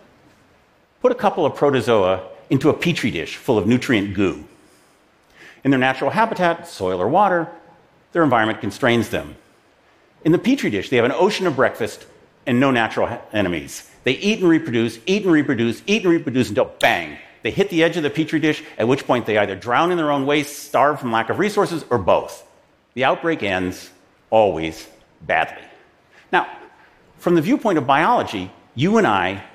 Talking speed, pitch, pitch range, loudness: 180 wpm, 145 Hz, 115-170 Hz, -19 LUFS